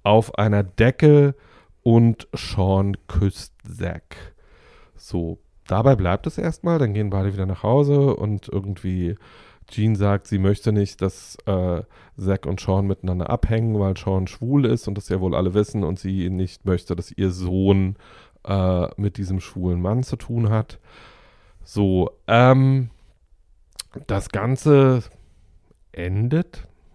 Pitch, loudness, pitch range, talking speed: 100 Hz, -21 LUFS, 90-115 Hz, 140 wpm